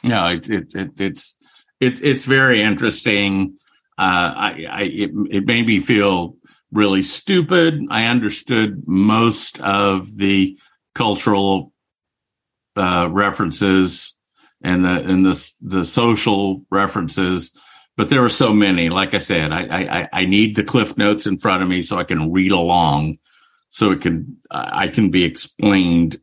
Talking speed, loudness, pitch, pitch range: 150 wpm, -17 LUFS, 95 Hz, 90-105 Hz